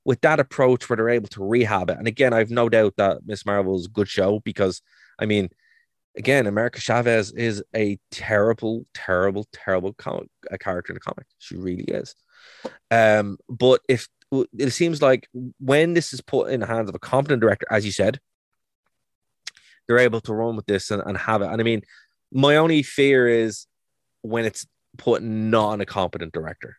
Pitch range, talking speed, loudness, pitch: 100-125 Hz, 195 wpm, -22 LUFS, 115 Hz